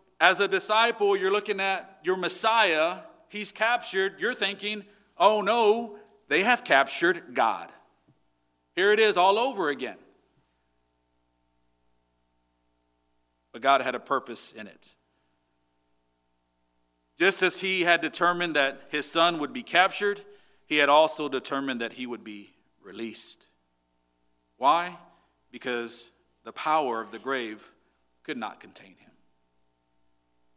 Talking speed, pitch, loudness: 120 wpm, 120 Hz, -25 LUFS